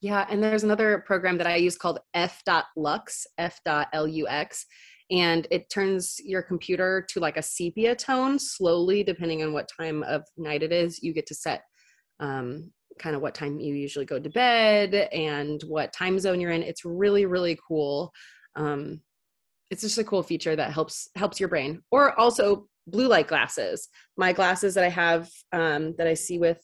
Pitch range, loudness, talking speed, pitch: 155-200 Hz, -26 LUFS, 180 wpm, 175 Hz